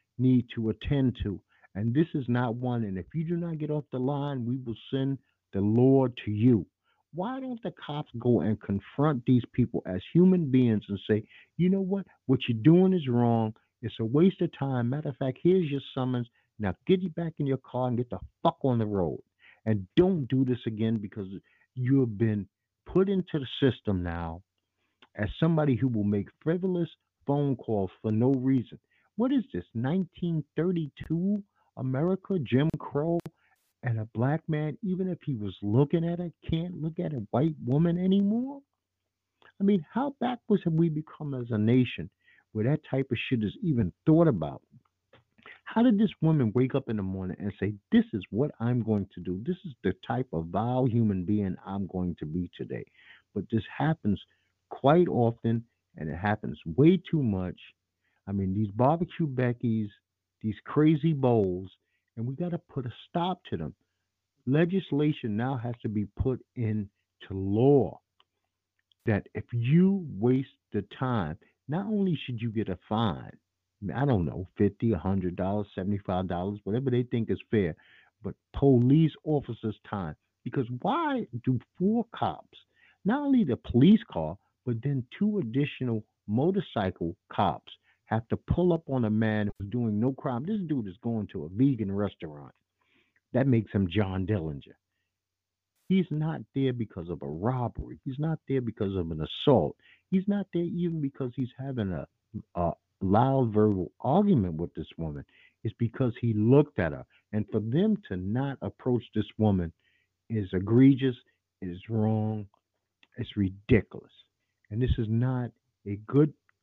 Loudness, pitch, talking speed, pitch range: -29 LUFS, 125 Hz, 170 wpm, 105-150 Hz